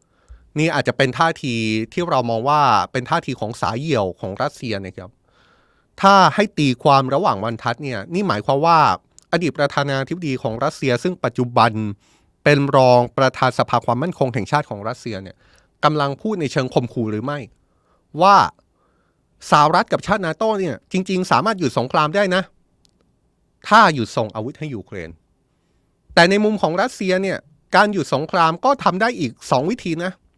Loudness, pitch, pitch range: -18 LUFS, 140 Hz, 120-170 Hz